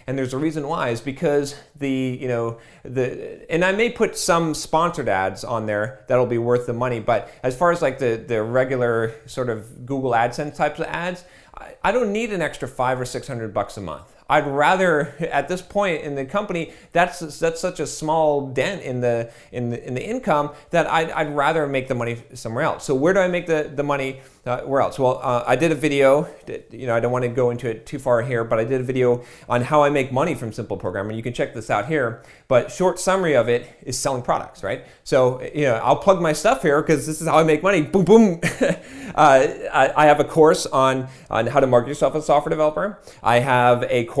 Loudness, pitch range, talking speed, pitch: -21 LUFS, 120-160 Hz, 240 wpm, 140 Hz